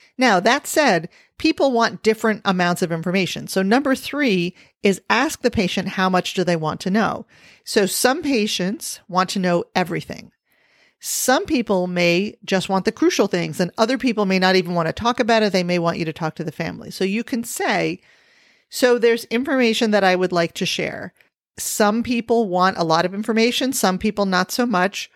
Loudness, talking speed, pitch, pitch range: -20 LUFS, 200 wpm, 200 Hz, 180-235 Hz